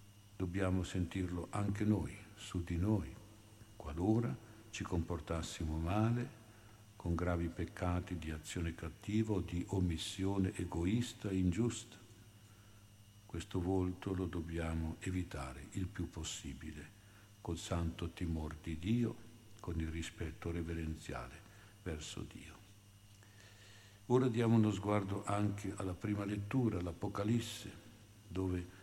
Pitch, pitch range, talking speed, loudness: 100 Hz, 85-105 Hz, 110 wpm, -39 LUFS